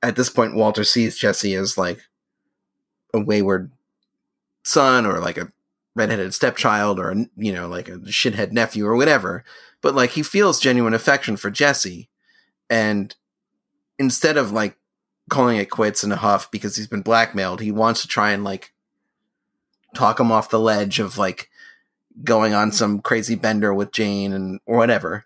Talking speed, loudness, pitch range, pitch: 165 wpm, -19 LUFS, 100-115 Hz, 110 Hz